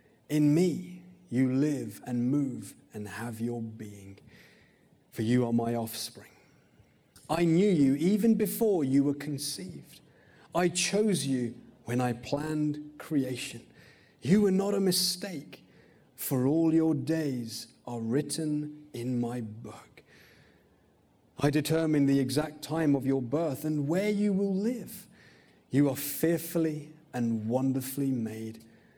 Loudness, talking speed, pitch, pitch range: -29 LUFS, 130 wpm, 140 Hz, 120-160 Hz